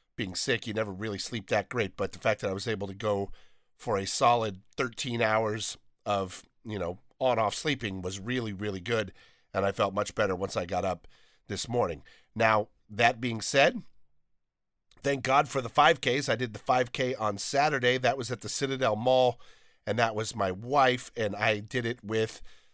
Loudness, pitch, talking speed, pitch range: -29 LUFS, 110 Hz, 195 wpm, 100-125 Hz